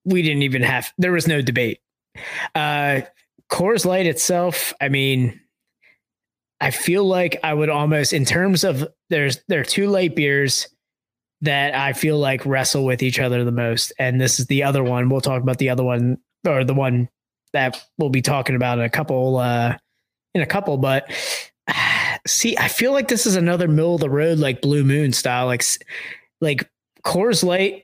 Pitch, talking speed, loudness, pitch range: 140 Hz, 190 wpm, -19 LUFS, 130-170 Hz